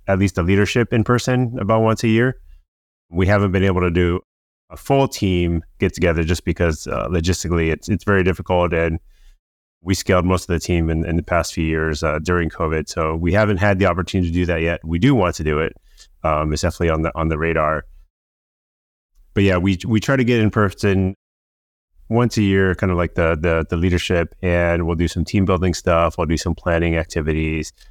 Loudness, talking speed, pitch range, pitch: -19 LUFS, 215 wpm, 80-95 Hz, 85 Hz